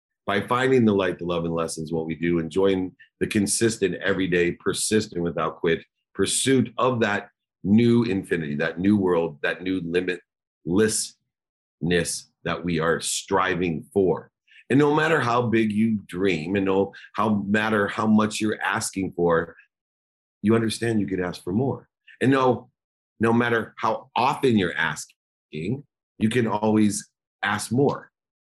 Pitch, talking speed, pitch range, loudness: 100 Hz, 150 wpm, 85-110 Hz, -23 LUFS